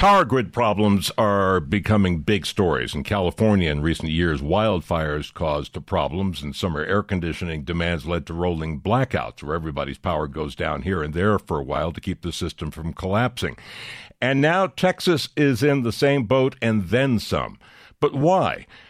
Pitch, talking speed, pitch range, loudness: 95 Hz, 175 wpm, 85-120 Hz, -22 LUFS